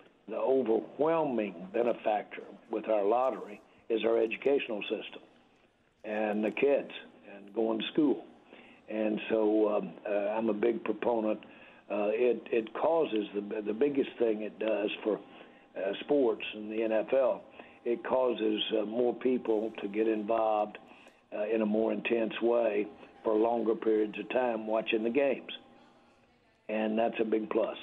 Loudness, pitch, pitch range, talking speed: -31 LUFS, 110 Hz, 110-115 Hz, 145 wpm